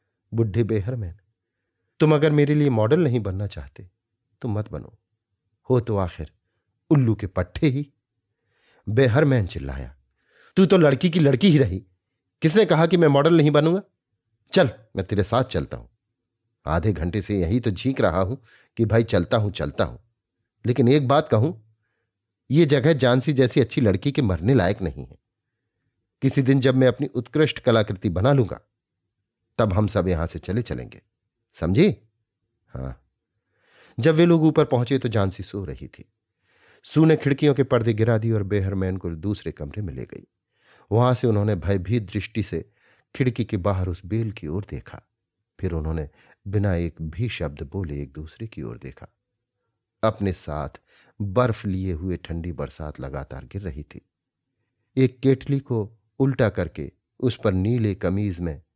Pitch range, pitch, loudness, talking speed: 95-125 Hz, 110 Hz, -22 LUFS, 165 wpm